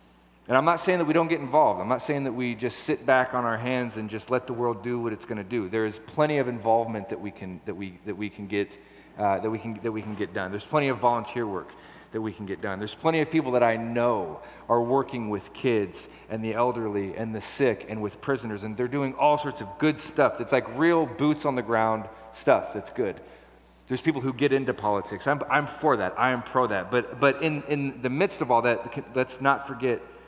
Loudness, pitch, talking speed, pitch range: -26 LUFS, 120 Hz, 230 wpm, 110-140 Hz